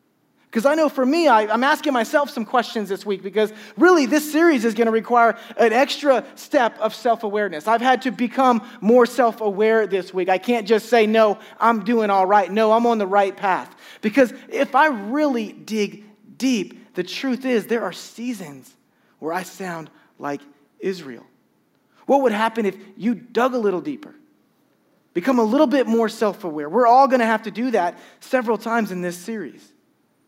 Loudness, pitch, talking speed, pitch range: -20 LUFS, 230 Hz, 190 wpm, 210-255 Hz